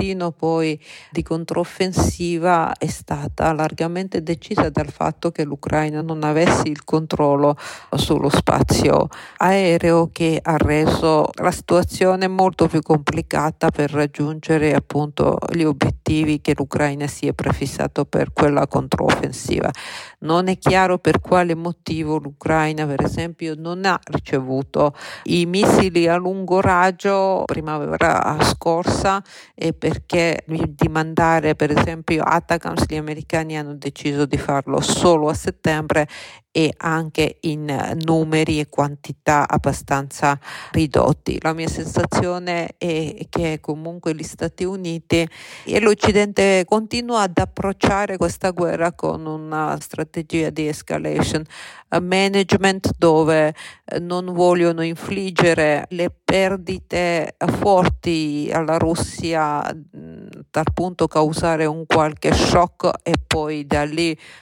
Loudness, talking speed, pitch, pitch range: -19 LUFS, 115 wpm, 160 Hz, 155-175 Hz